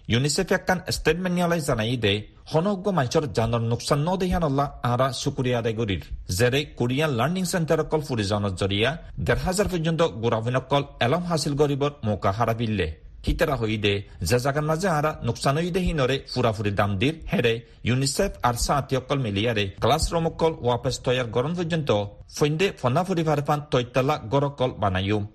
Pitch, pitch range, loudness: 130 Hz, 115-160 Hz, -24 LUFS